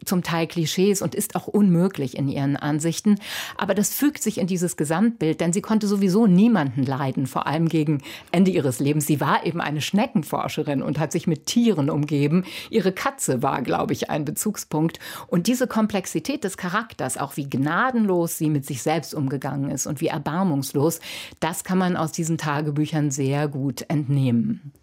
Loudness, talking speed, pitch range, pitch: -23 LUFS, 175 wpm, 150-195 Hz, 165 Hz